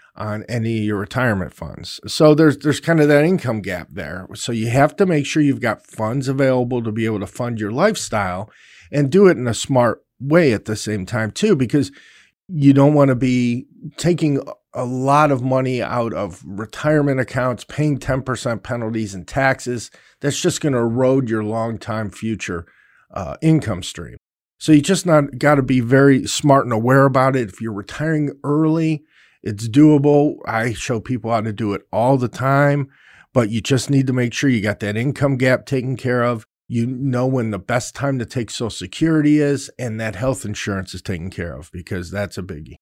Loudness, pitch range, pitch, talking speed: -18 LUFS, 110-140 Hz, 125 Hz, 200 wpm